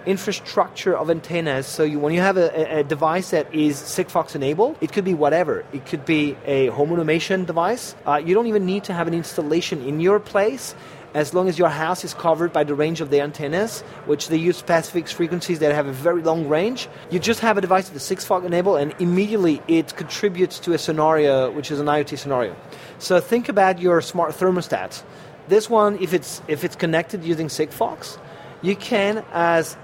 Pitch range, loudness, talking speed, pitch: 150-185 Hz, -21 LUFS, 205 wpm, 170 Hz